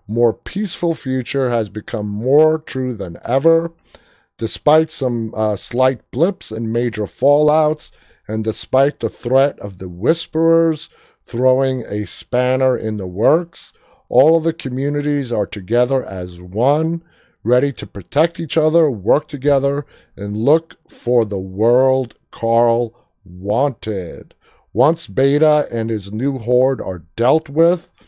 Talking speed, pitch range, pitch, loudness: 130 wpm, 110-150 Hz, 130 Hz, -17 LUFS